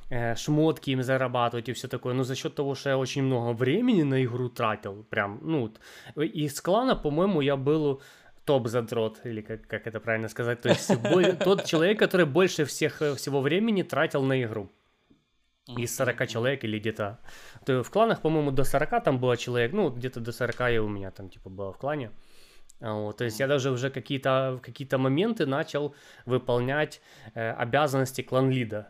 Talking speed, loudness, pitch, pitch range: 185 wpm, -27 LUFS, 130 Hz, 120-150 Hz